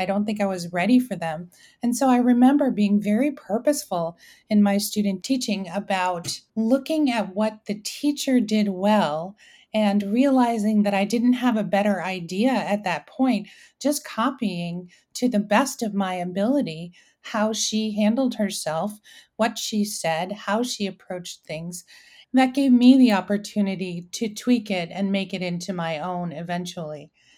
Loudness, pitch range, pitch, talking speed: -23 LUFS, 185-240 Hz, 205 Hz, 160 wpm